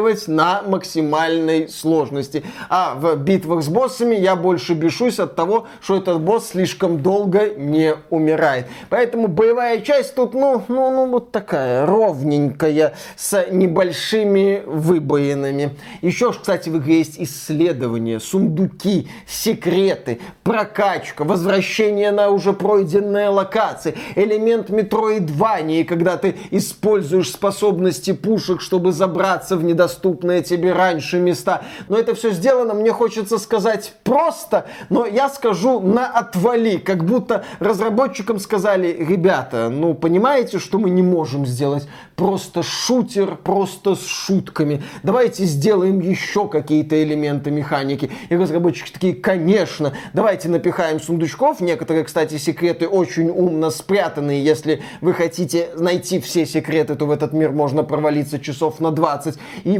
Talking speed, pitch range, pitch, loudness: 125 wpm, 160-210 Hz, 185 Hz, -18 LUFS